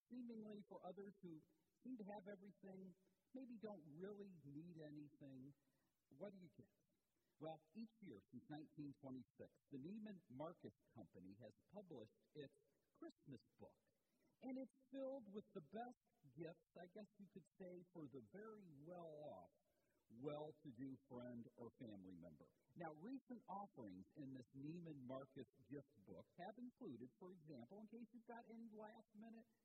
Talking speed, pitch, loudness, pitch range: 145 wpm, 180 Hz, -60 LUFS, 145-215 Hz